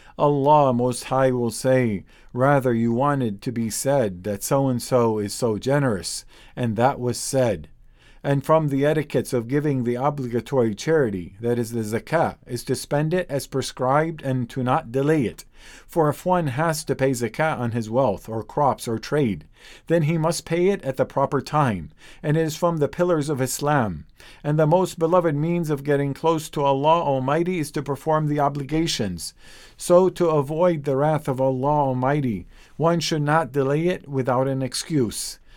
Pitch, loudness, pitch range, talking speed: 140 Hz, -22 LUFS, 125-155 Hz, 185 wpm